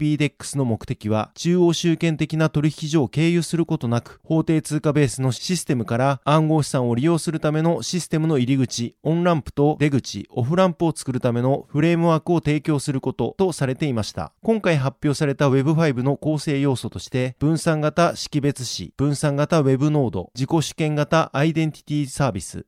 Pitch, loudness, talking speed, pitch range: 150 Hz, -21 LUFS, 400 characters per minute, 130-160 Hz